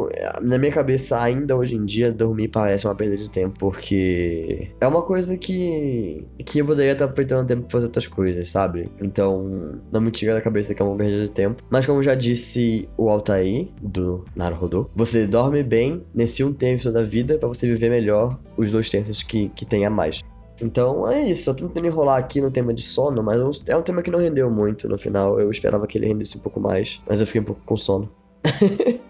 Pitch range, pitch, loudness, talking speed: 100-130 Hz, 115 Hz, -21 LUFS, 220 wpm